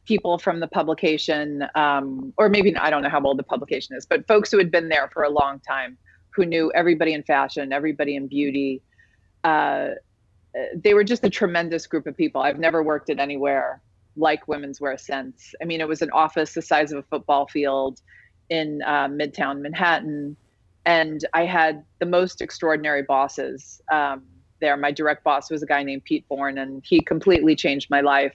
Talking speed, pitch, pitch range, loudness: 195 wpm, 150 Hz, 140-165 Hz, -22 LUFS